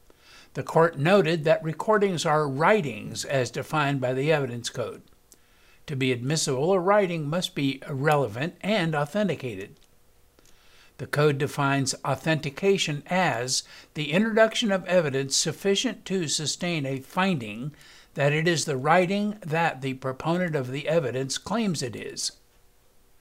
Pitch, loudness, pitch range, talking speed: 155 Hz, -25 LUFS, 135-180 Hz, 130 wpm